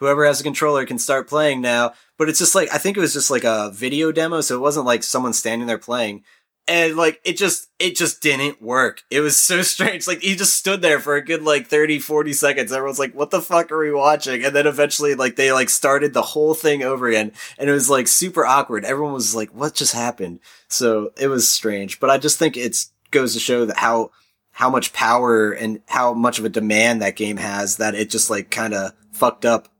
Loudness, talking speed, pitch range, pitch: -18 LUFS, 240 wpm, 115-150 Hz, 140 Hz